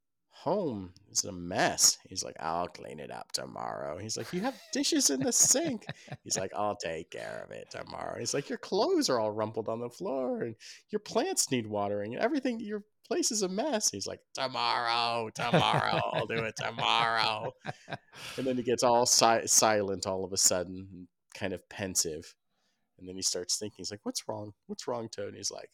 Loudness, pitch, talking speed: -30 LUFS, 120 Hz, 200 wpm